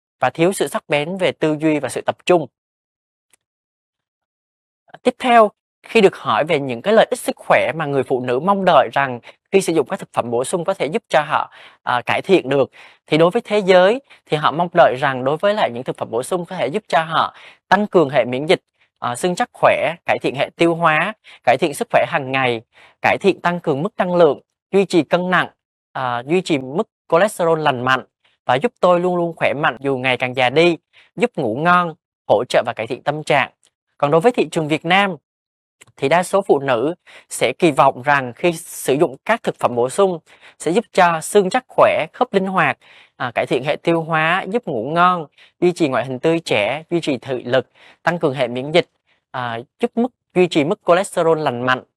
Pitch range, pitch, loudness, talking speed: 140-195 Hz, 170 Hz, -18 LUFS, 225 wpm